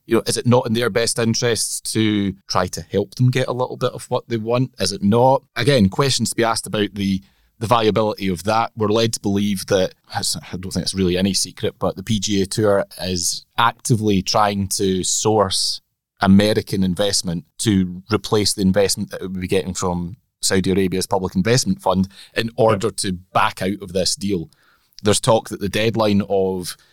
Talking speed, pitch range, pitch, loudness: 195 wpm, 95-115 Hz, 100 Hz, -19 LUFS